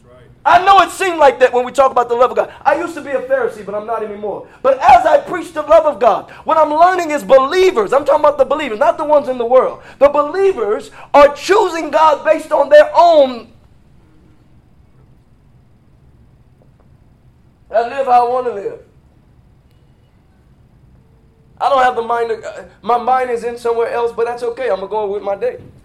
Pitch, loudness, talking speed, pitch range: 280 Hz, -13 LUFS, 200 wpm, 240-315 Hz